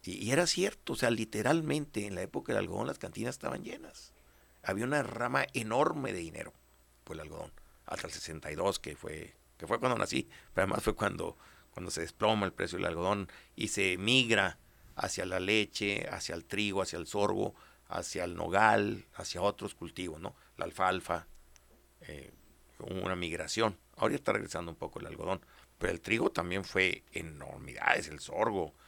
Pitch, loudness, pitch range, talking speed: 95 Hz, -33 LUFS, 80-110 Hz, 175 wpm